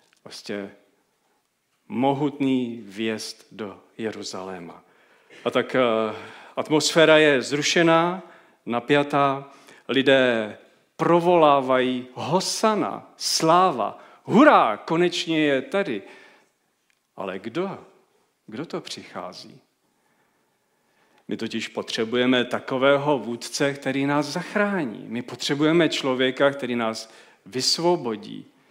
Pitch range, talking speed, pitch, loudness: 115-155 Hz, 80 wpm, 135 Hz, -22 LUFS